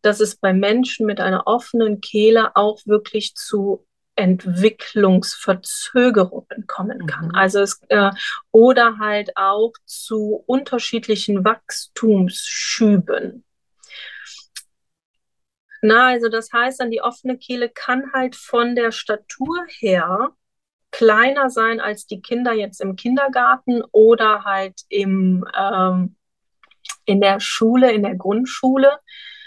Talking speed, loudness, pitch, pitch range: 110 wpm, -18 LUFS, 220 Hz, 200-250 Hz